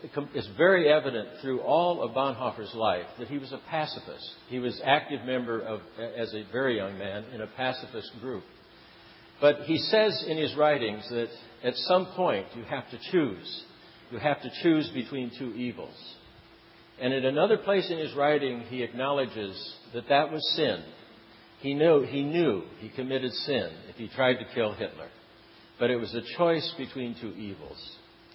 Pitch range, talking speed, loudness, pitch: 115-150 Hz, 175 wpm, -28 LUFS, 130 Hz